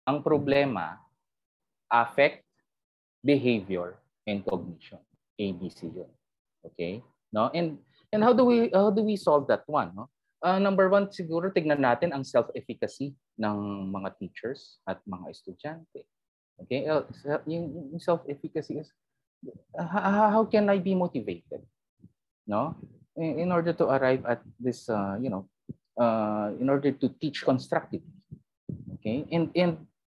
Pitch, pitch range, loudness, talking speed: 150 Hz, 120-175 Hz, -28 LUFS, 140 wpm